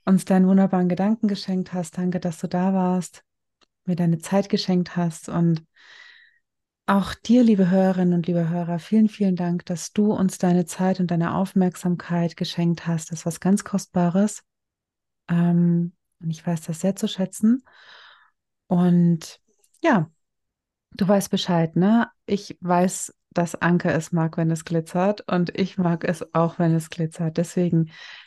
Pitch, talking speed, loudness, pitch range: 180 Hz, 155 wpm, -22 LUFS, 170-195 Hz